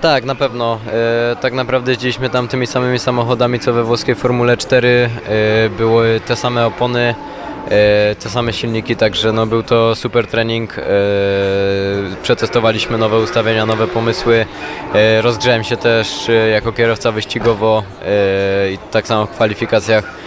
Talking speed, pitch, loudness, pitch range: 150 wpm, 115 Hz, -14 LUFS, 110-120 Hz